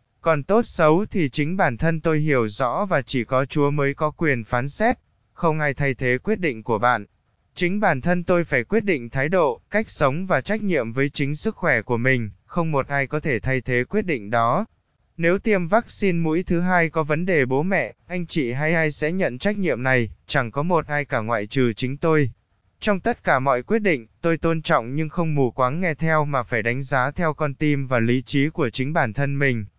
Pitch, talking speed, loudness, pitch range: 150 Hz, 235 wpm, -22 LUFS, 125-170 Hz